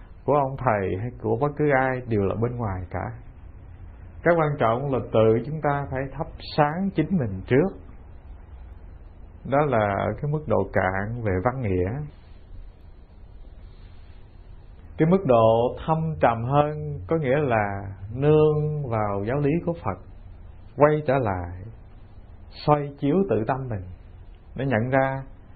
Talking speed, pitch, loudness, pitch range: 145 wpm, 110 Hz, -24 LUFS, 90-140 Hz